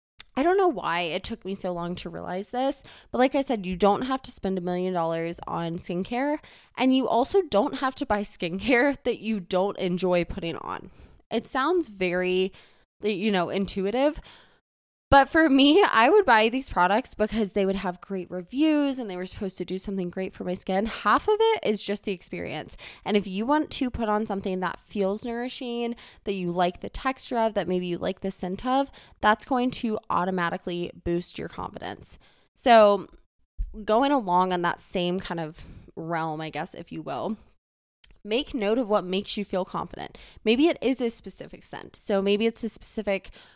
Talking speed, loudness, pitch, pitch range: 195 wpm, -26 LUFS, 205 Hz, 185-245 Hz